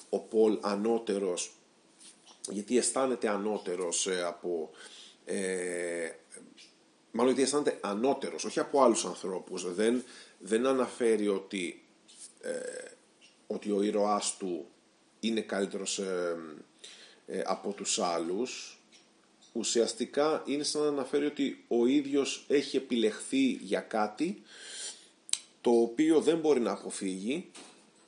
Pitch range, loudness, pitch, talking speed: 100-140 Hz, -31 LUFS, 115 Hz, 105 wpm